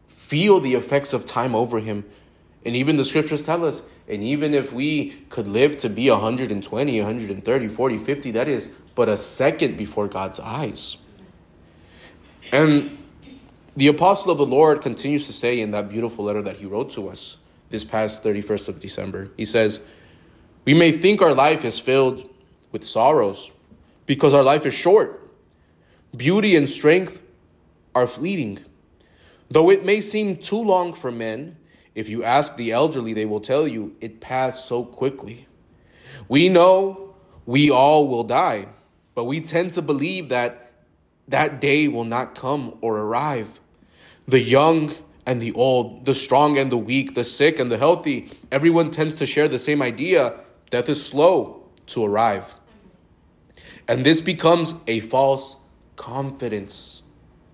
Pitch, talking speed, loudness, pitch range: 130 Hz, 155 wpm, -20 LUFS, 110-150 Hz